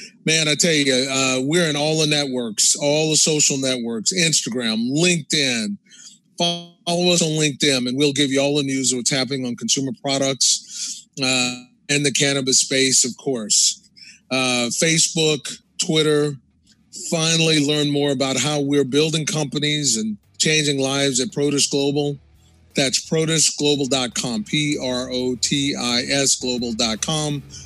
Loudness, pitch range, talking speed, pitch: -18 LUFS, 130-160 Hz, 145 wpm, 145 Hz